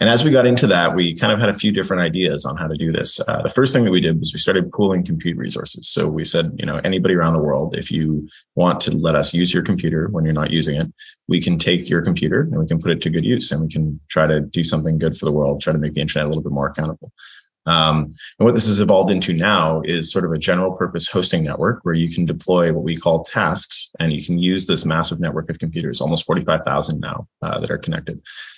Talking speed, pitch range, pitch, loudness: 270 wpm, 80-90 Hz, 85 Hz, -18 LUFS